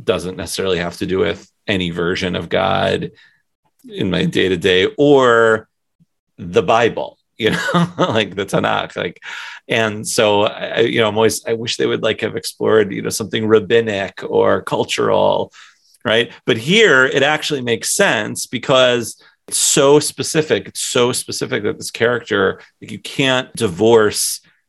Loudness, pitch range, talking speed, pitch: -16 LUFS, 110-135 Hz, 160 wpm, 115 Hz